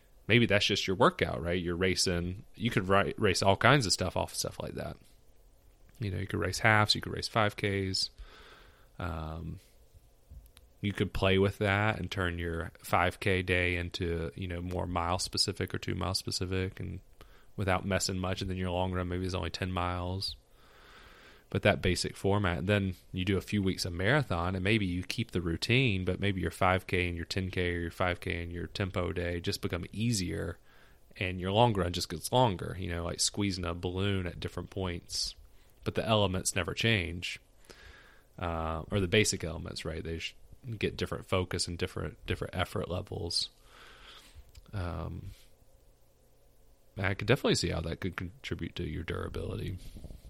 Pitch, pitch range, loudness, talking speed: 90 Hz, 85-100 Hz, -31 LUFS, 180 wpm